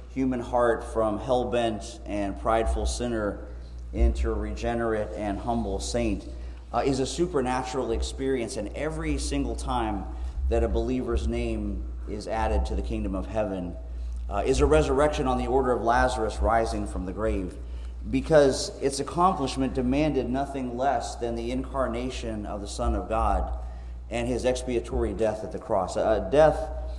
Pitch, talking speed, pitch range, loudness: 115 Hz, 155 wpm, 95-130 Hz, -27 LUFS